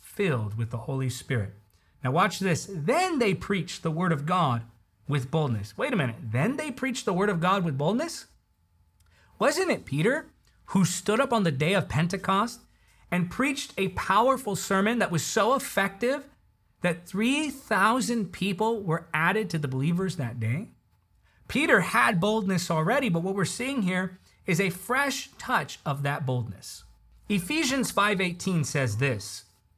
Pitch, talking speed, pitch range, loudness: 185 Hz, 160 wpm, 140-220 Hz, -27 LUFS